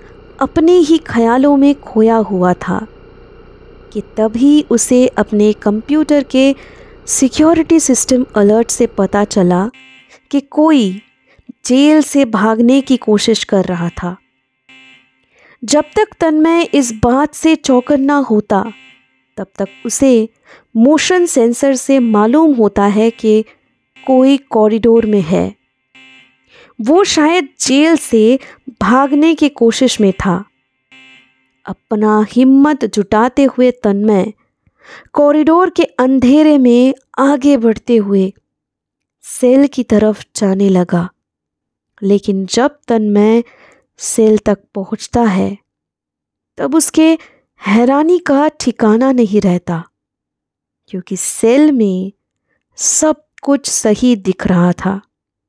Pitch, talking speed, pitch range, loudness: 230 Hz, 110 wpm, 200-280 Hz, -12 LUFS